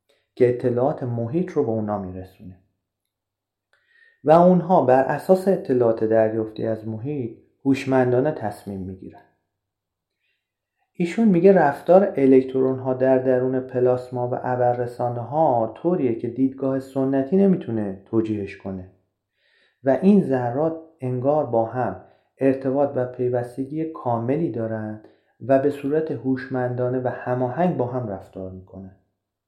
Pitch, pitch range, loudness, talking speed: 125 Hz, 110-140 Hz, -21 LUFS, 115 wpm